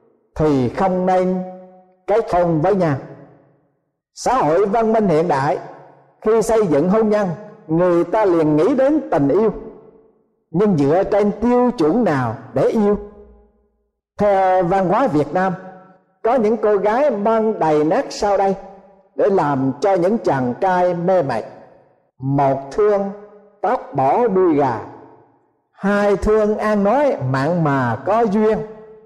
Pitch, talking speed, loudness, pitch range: 195 Hz, 140 wpm, -17 LUFS, 170-215 Hz